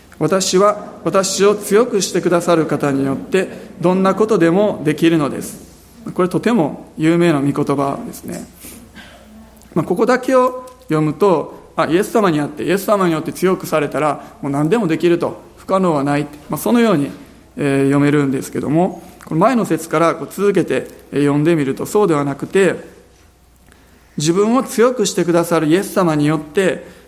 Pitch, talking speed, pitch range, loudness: 170 Hz, 340 characters per minute, 150-205 Hz, -16 LUFS